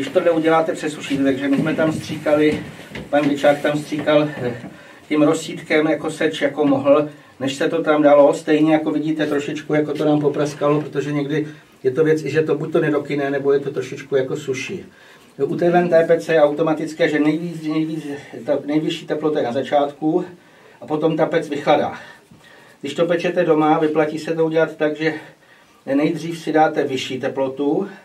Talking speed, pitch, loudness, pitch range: 180 wpm, 155 Hz, -19 LUFS, 145-160 Hz